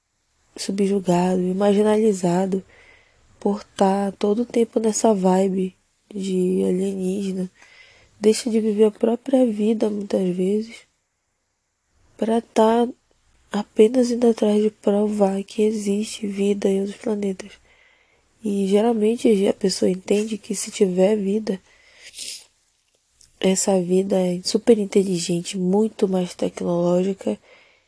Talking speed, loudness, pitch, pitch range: 110 wpm, -21 LUFS, 205 Hz, 190-225 Hz